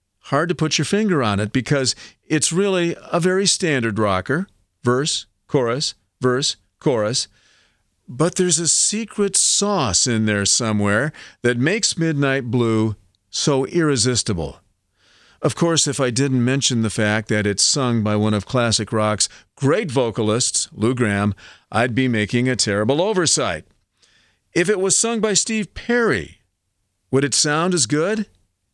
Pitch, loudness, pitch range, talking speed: 125 Hz, -19 LUFS, 105-160 Hz, 145 wpm